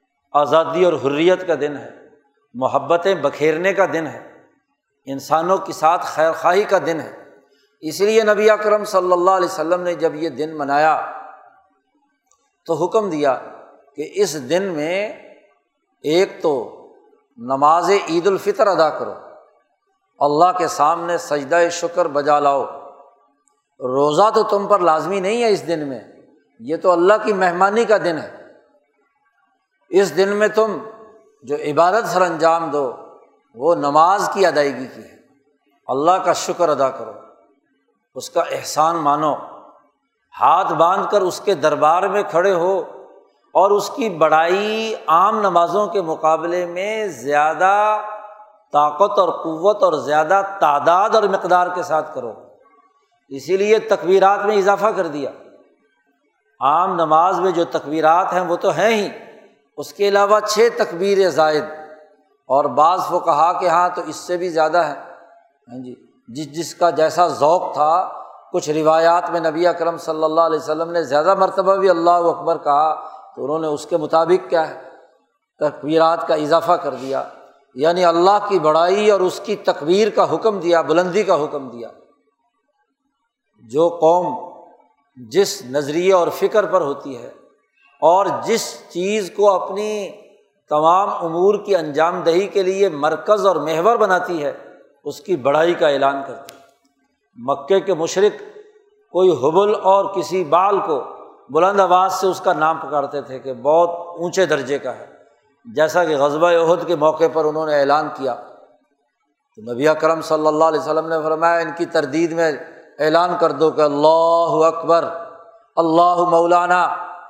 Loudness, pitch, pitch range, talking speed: -17 LUFS, 175 Hz, 155-200 Hz, 155 wpm